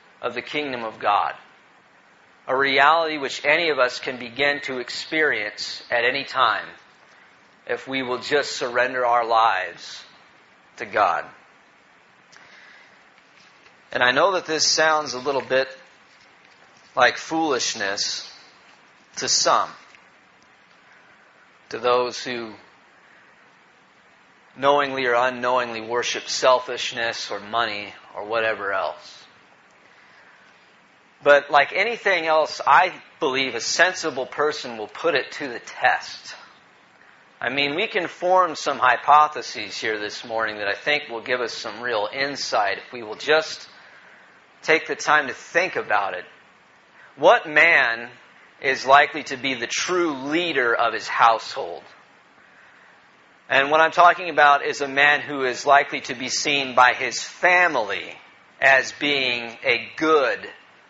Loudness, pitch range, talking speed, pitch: -21 LUFS, 120-150 Hz, 130 wpm, 135 Hz